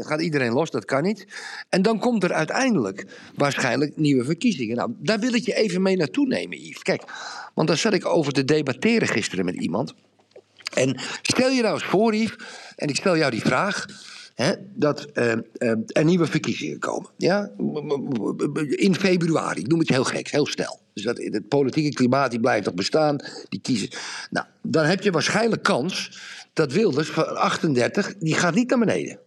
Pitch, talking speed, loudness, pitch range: 170 Hz, 185 wpm, -23 LUFS, 145-220 Hz